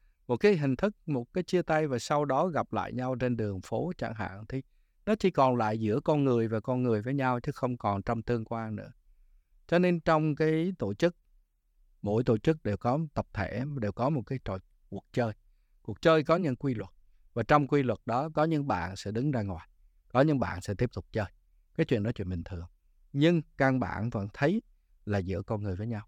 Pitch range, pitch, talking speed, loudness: 100-145 Hz, 120 Hz, 230 wpm, -30 LUFS